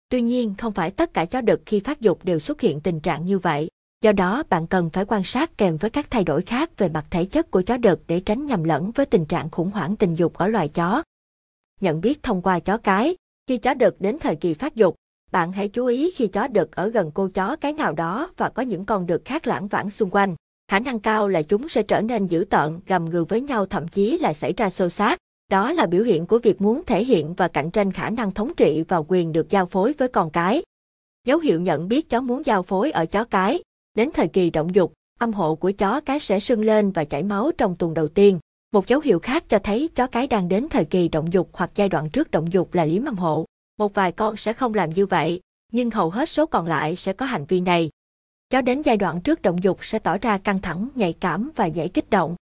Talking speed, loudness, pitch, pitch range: 260 wpm, -22 LUFS, 200 Hz, 175-235 Hz